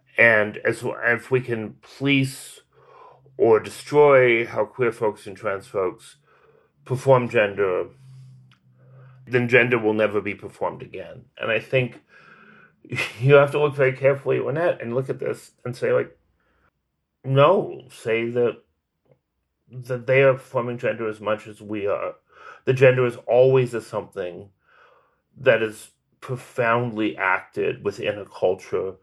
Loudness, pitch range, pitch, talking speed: -21 LUFS, 115-140 Hz, 130 Hz, 140 wpm